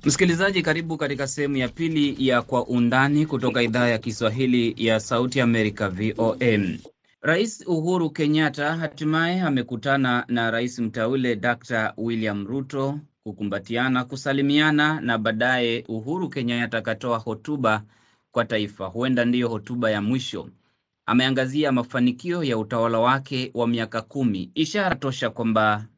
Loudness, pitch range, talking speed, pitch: -23 LUFS, 115-145 Hz, 120 wpm, 125 Hz